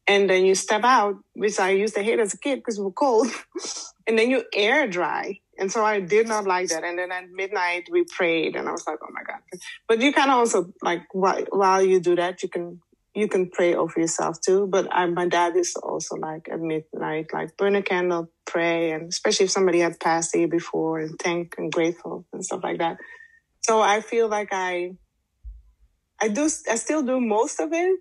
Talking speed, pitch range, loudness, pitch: 225 wpm, 175-215 Hz, -23 LUFS, 190 Hz